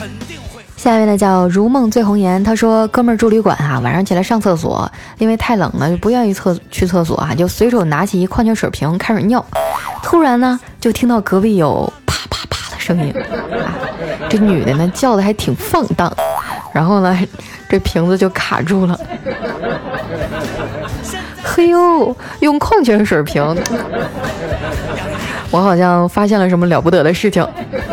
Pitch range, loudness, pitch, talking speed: 175-225 Hz, -14 LUFS, 195 Hz, 240 characters per minute